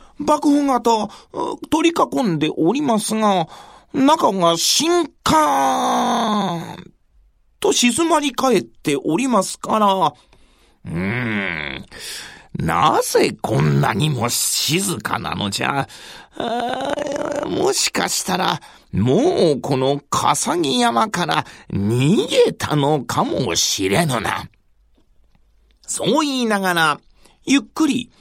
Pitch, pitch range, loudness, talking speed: 260 Hz, 200-315 Hz, -18 LUFS, 175 characters per minute